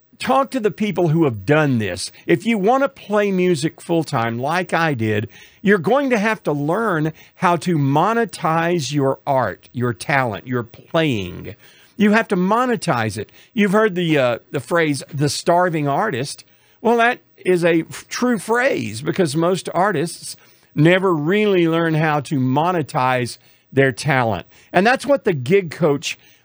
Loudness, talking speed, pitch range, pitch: -19 LUFS, 170 wpm, 140-200 Hz, 165 Hz